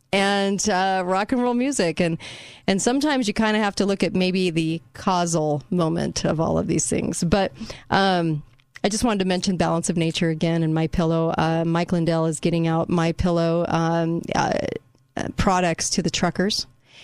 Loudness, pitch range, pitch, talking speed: -22 LUFS, 165-195 Hz, 175 Hz, 185 wpm